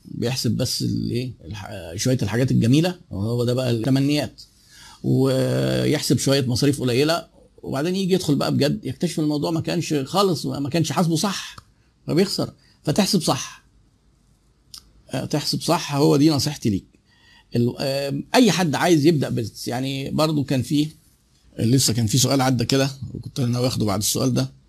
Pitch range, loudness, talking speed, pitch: 120-150 Hz, -21 LUFS, 140 wpm, 135 Hz